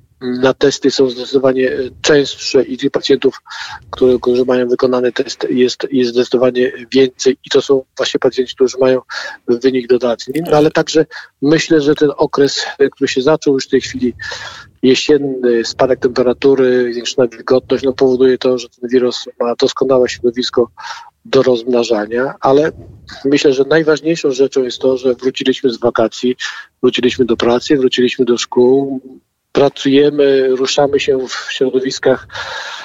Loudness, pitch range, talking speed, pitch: -14 LUFS, 125-135 Hz, 140 wpm, 130 Hz